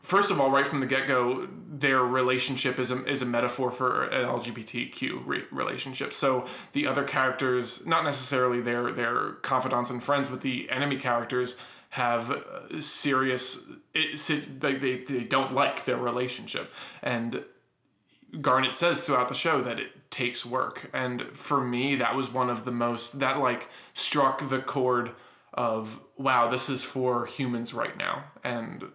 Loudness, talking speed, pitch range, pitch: -28 LUFS, 160 wpm, 125-135 Hz, 130 Hz